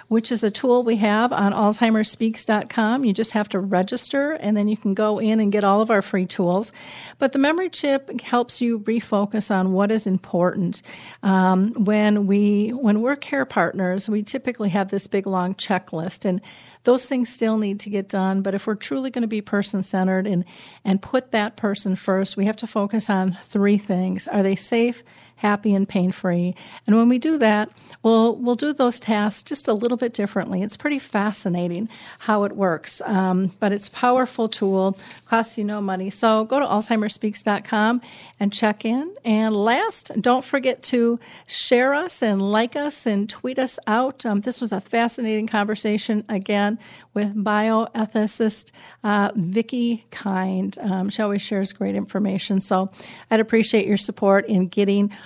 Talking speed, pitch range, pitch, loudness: 175 wpm, 195-230 Hz, 210 Hz, -22 LUFS